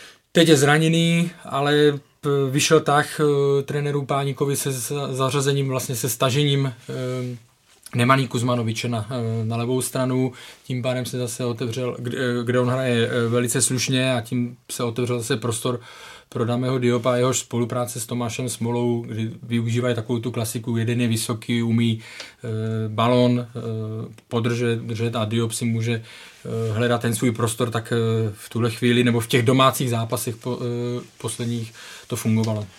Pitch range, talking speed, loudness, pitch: 115-130 Hz, 150 wpm, -22 LUFS, 125 Hz